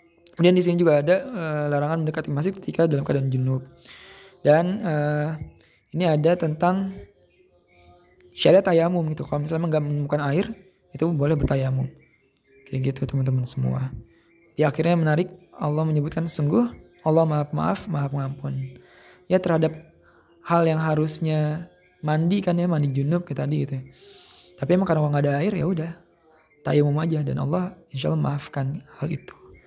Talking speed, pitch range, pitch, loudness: 150 wpm, 140-170 Hz, 155 Hz, -23 LUFS